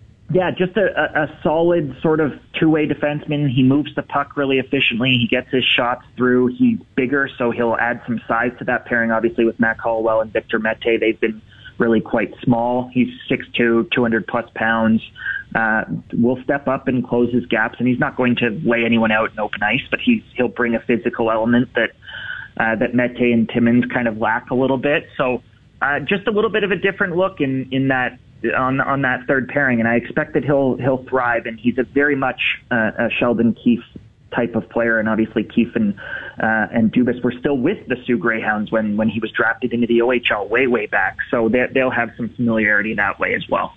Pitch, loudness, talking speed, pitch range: 120 Hz, -18 LUFS, 215 wpm, 115-140 Hz